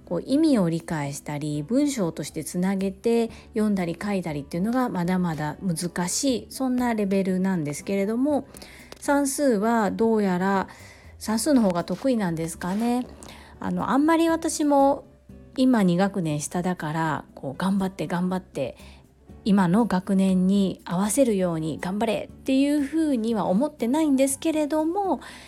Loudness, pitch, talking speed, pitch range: -24 LUFS, 195 Hz, 310 characters per minute, 180-260 Hz